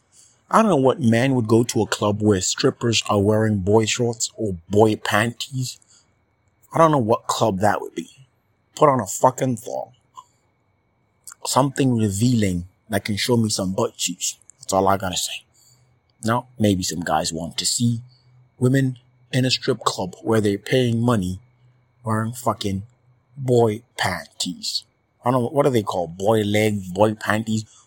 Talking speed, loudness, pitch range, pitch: 165 wpm, -21 LUFS, 105-125 Hz, 115 Hz